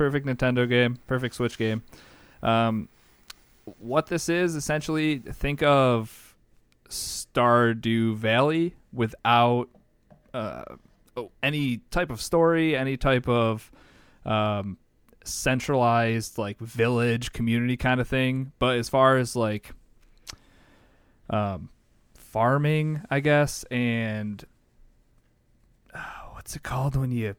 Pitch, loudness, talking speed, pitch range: 120 Hz, -25 LUFS, 105 wpm, 110-135 Hz